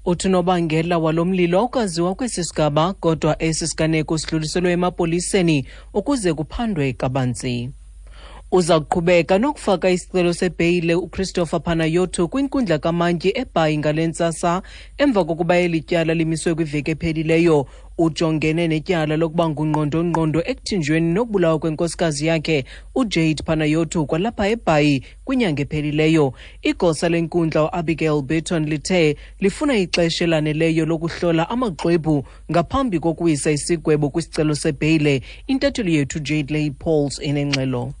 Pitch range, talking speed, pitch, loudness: 155-180 Hz, 105 wpm, 165 Hz, -20 LUFS